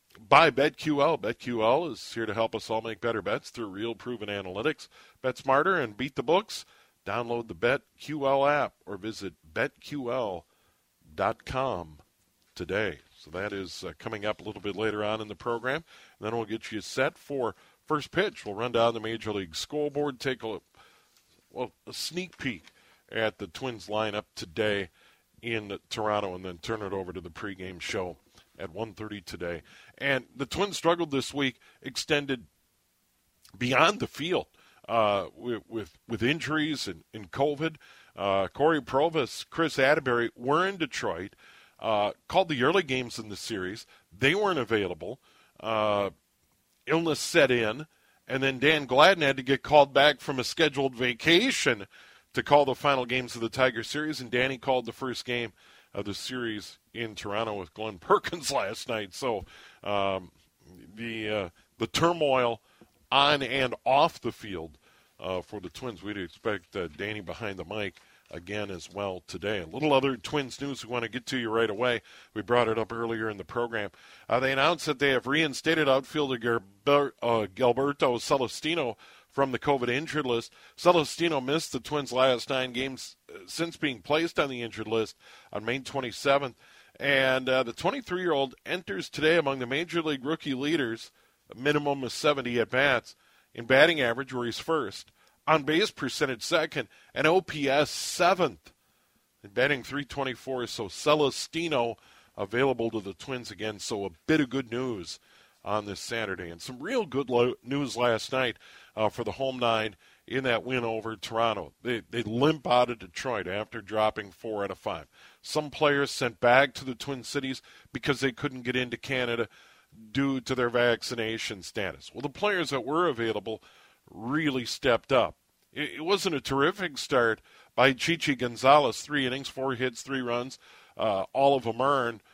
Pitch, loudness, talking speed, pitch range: 125 Hz, -28 LUFS, 170 wpm, 110-140 Hz